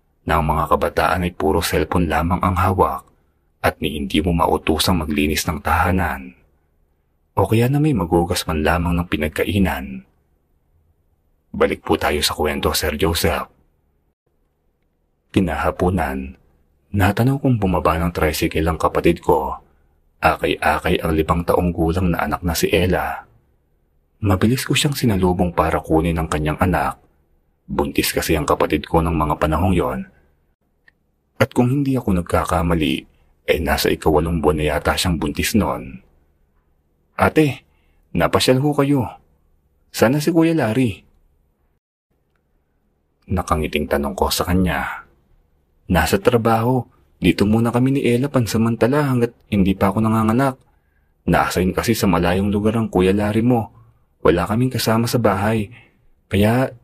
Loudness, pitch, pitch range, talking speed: -19 LUFS, 80 Hz, 70-105 Hz, 135 wpm